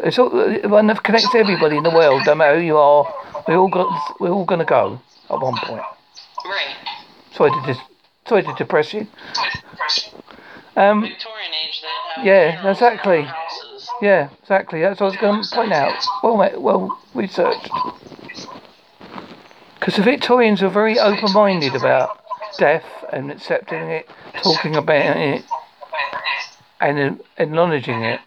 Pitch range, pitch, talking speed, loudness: 165-245 Hz, 205 Hz, 135 wpm, -17 LUFS